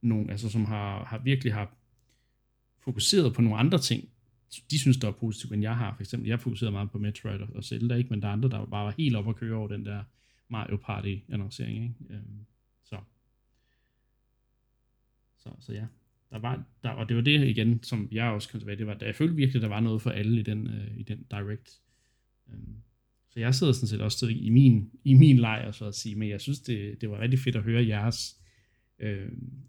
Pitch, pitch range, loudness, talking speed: 115 Hz, 110-120 Hz, -28 LUFS, 220 wpm